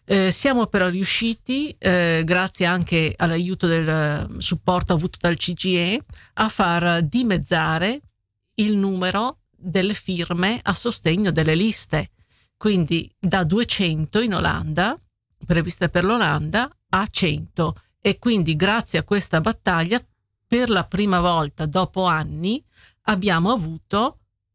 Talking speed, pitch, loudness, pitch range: 115 wpm, 185 Hz, -21 LUFS, 165-205 Hz